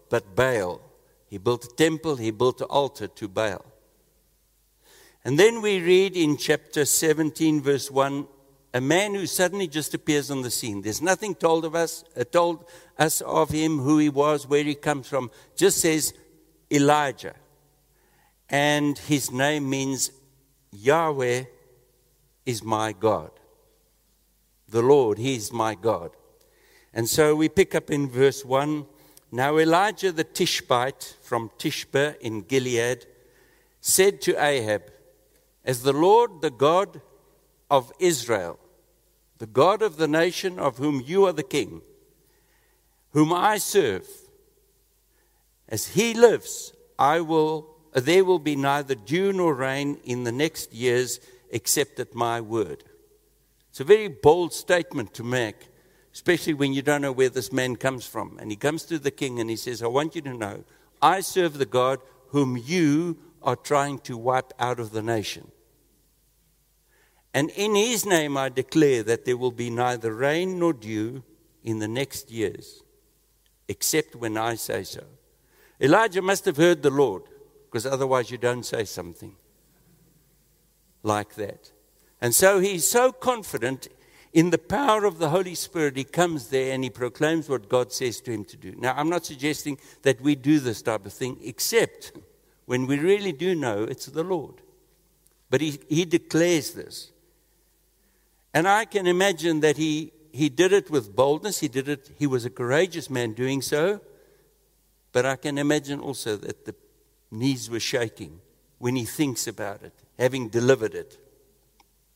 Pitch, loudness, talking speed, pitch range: 145 Hz, -24 LUFS, 155 wpm, 125-170 Hz